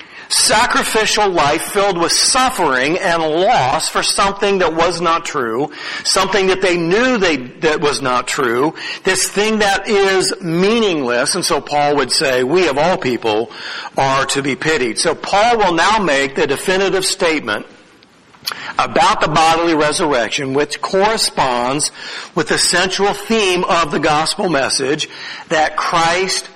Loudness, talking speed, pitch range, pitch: -15 LUFS, 145 wpm, 150-200 Hz, 180 Hz